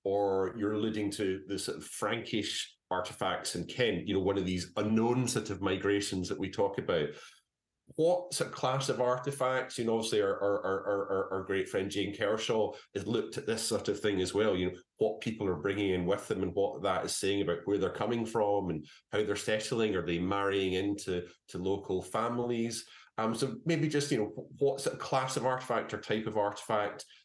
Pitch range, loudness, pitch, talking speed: 95-115 Hz, -33 LUFS, 105 Hz, 215 wpm